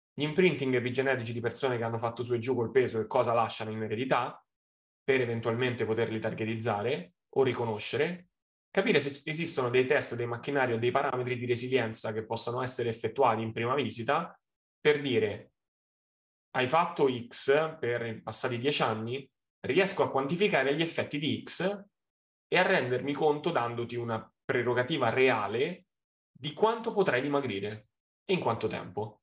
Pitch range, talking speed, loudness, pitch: 115-145 Hz, 155 wpm, -30 LUFS, 125 Hz